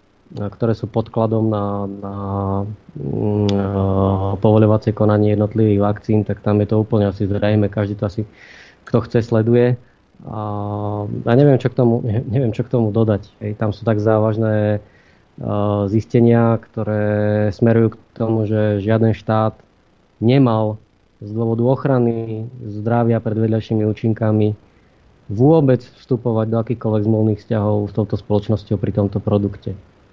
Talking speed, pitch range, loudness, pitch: 130 wpm, 105-115 Hz, -18 LUFS, 110 Hz